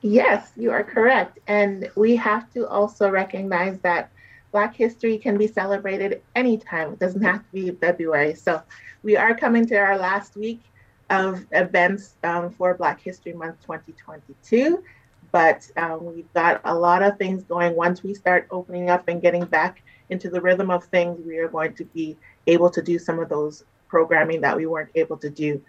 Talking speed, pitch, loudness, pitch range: 185 wpm, 180 Hz, -21 LUFS, 165-200 Hz